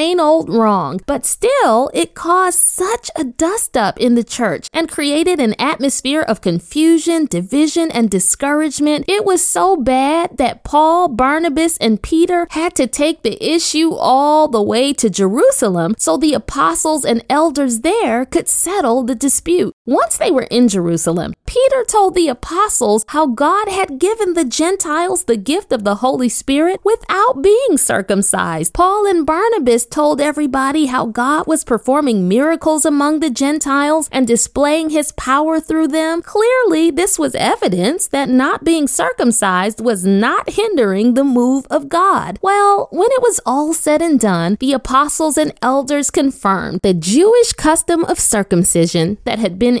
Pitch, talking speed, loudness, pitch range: 295 Hz, 160 wpm, -14 LUFS, 240-335 Hz